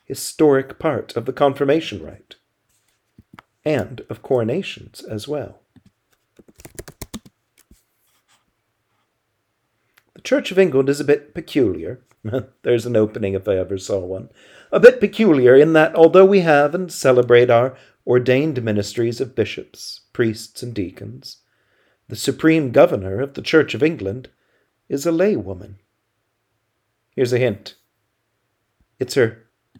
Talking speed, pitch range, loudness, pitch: 125 wpm, 110-150 Hz, -17 LUFS, 130 Hz